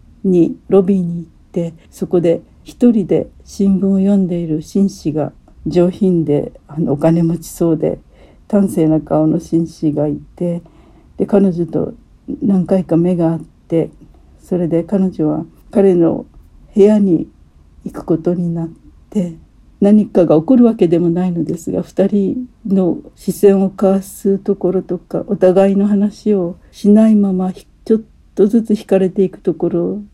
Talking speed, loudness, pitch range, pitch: 265 characters per minute, -15 LUFS, 165-200 Hz, 180 Hz